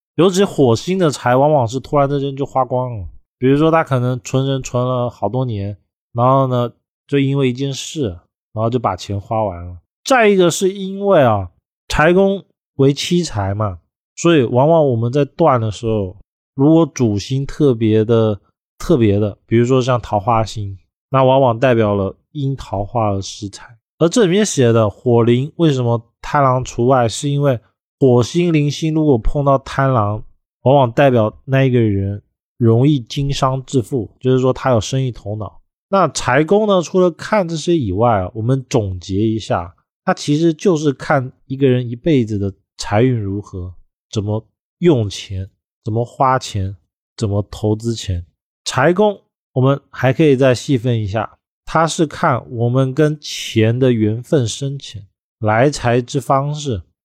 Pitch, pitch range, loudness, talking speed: 125 Hz, 105-145 Hz, -16 LUFS, 240 characters per minute